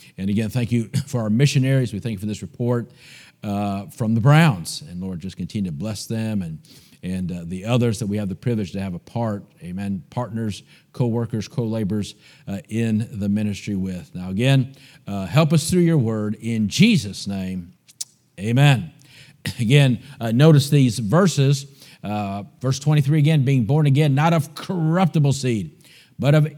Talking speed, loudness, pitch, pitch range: 165 wpm, -21 LUFS, 120 Hz, 105-145 Hz